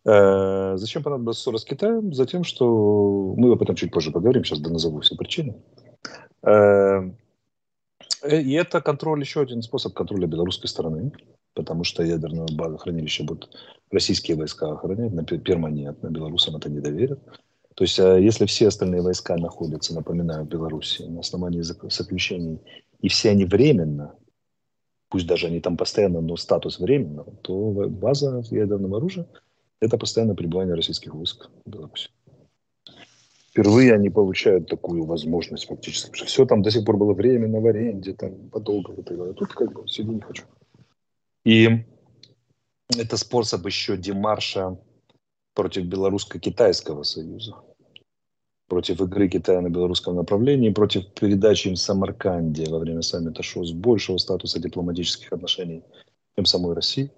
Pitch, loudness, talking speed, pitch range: 95 Hz, -22 LUFS, 135 wpm, 85-115 Hz